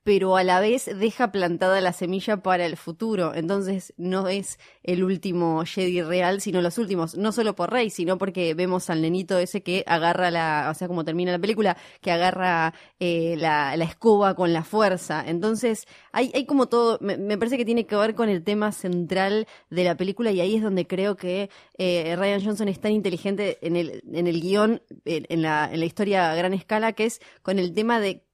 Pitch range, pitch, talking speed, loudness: 175-210 Hz, 185 Hz, 210 wpm, -24 LUFS